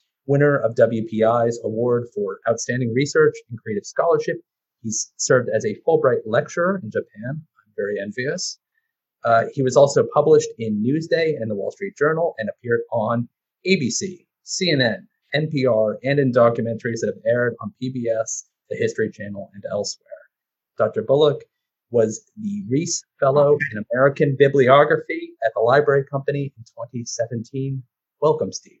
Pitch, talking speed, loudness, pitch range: 140 Hz, 145 wpm, -20 LUFS, 120-190 Hz